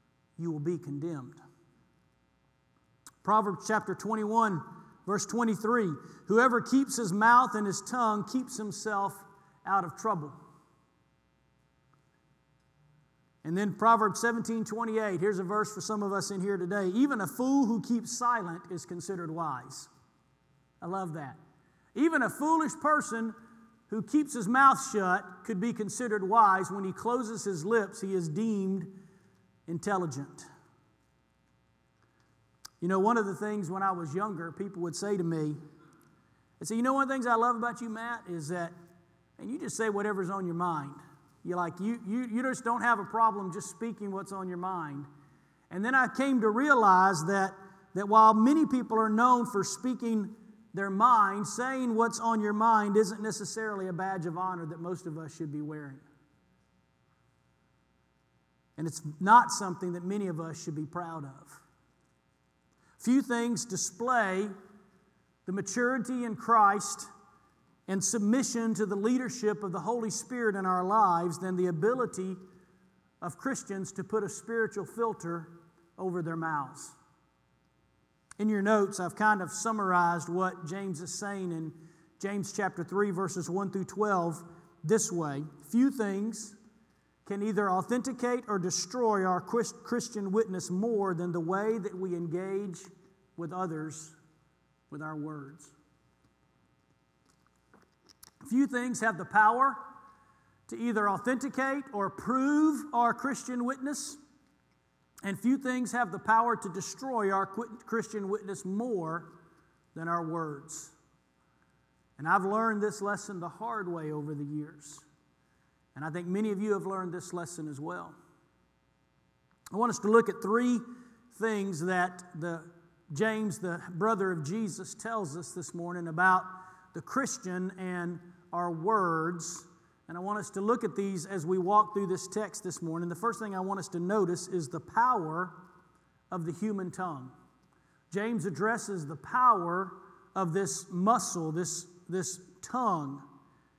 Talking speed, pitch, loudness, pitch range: 150 wpm, 190 Hz, -30 LUFS, 170-220 Hz